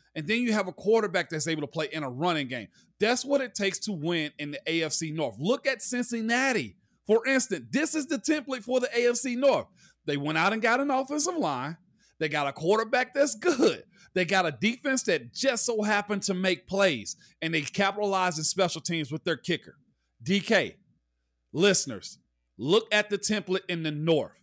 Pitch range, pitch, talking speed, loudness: 160-240 Hz, 195 Hz, 195 wpm, -27 LUFS